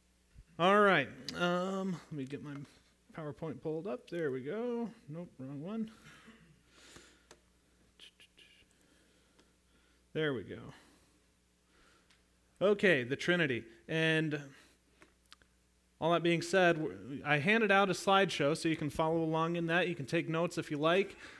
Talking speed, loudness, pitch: 130 wpm, -33 LUFS, 155 Hz